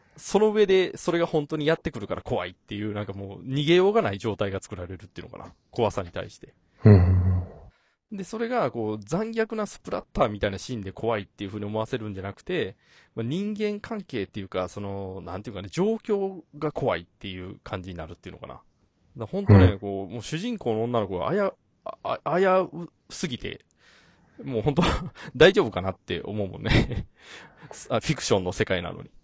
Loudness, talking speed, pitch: -26 LUFS, 385 characters per minute, 110 Hz